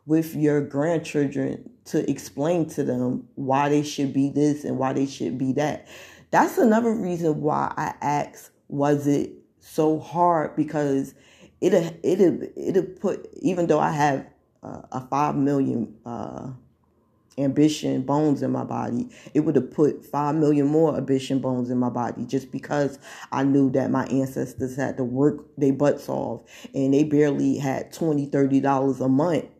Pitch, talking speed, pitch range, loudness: 140 Hz, 165 wpm, 135-150 Hz, -23 LUFS